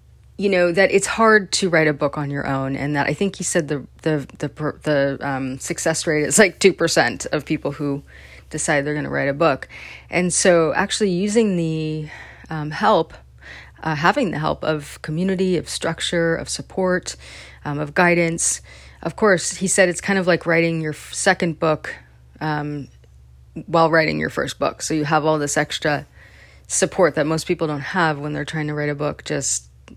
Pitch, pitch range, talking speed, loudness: 155 Hz, 140-175 Hz, 195 wpm, -20 LUFS